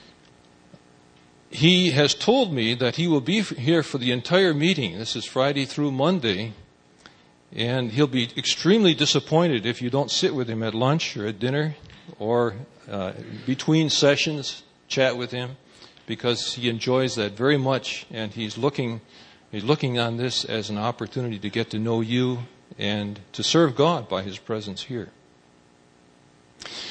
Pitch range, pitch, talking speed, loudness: 105-145 Hz, 120 Hz, 165 wpm, -23 LUFS